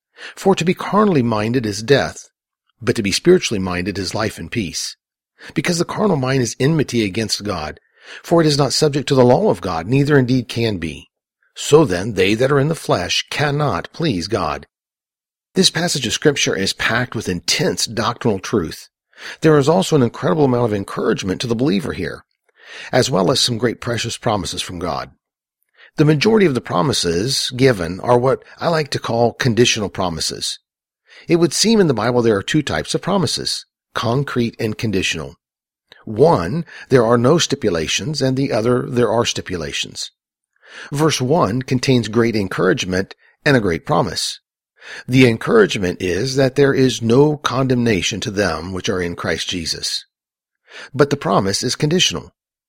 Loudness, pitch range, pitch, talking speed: -17 LUFS, 105-145 Hz, 125 Hz, 170 wpm